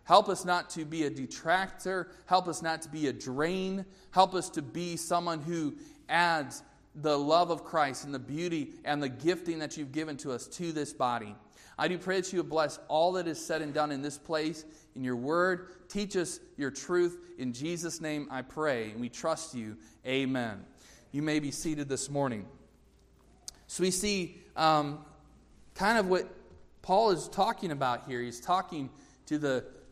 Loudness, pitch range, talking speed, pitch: -32 LUFS, 135-175 Hz, 190 wpm, 155 Hz